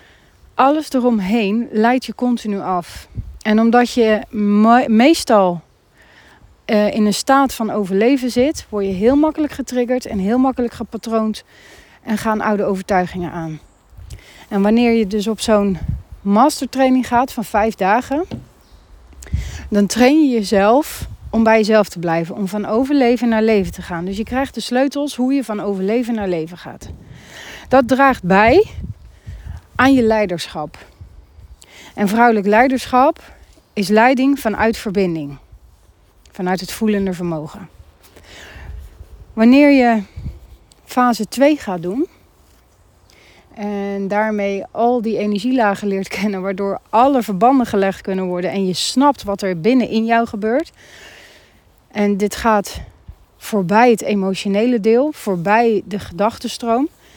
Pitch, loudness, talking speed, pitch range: 215 Hz, -16 LUFS, 130 wpm, 195-245 Hz